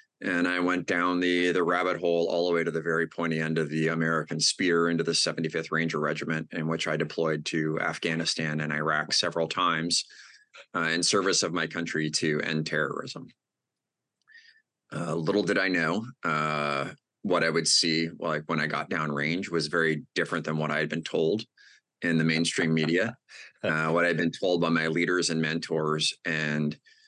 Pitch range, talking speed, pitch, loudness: 80-85 Hz, 190 wpm, 80 Hz, -27 LUFS